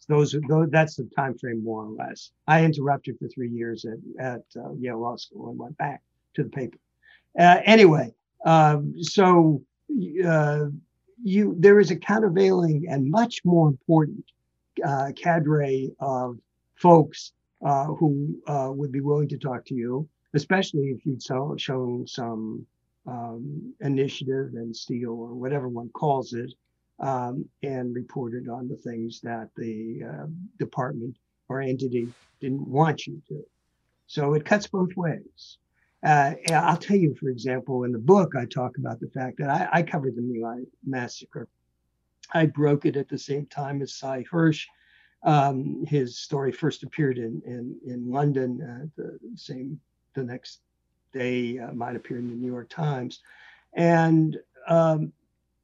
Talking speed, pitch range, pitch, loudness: 160 wpm, 120-155 Hz, 135 Hz, -24 LUFS